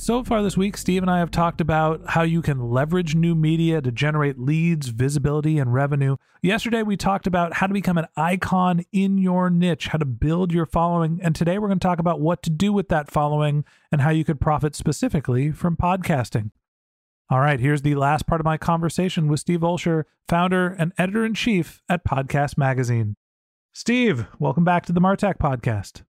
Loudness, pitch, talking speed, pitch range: -21 LUFS, 165 Hz, 200 wpm, 145-180 Hz